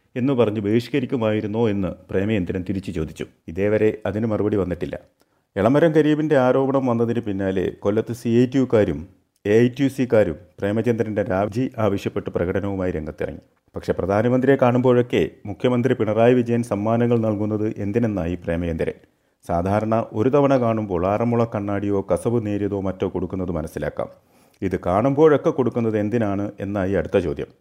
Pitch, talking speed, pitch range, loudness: 110 Hz, 125 wpm, 95-120 Hz, -21 LUFS